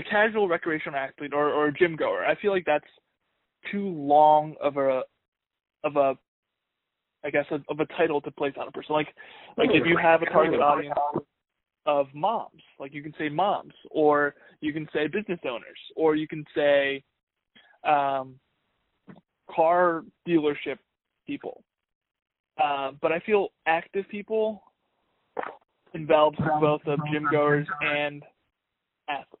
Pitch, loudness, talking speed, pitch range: 150 Hz, -25 LUFS, 145 wpm, 145-165 Hz